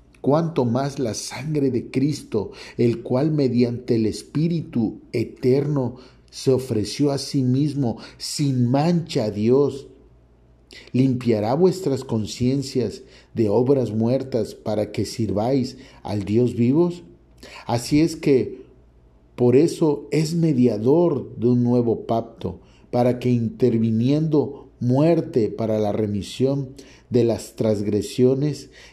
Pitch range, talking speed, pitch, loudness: 115-140 Hz, 110 wpm, 125 Hz, -22 LUFS